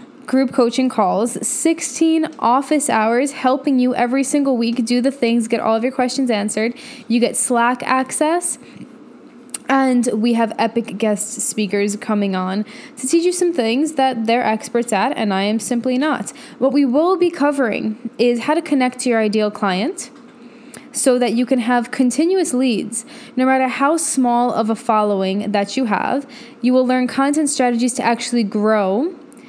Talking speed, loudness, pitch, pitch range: 170 wpm, -17 LUFS, 250 Hz, 230-270 Hz